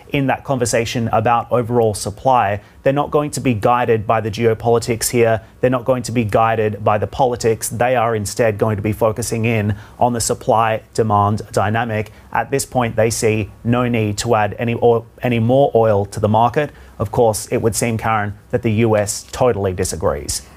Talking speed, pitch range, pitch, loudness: 195 wpm, 105-120 Hz, 115 Hz, -17 LUFS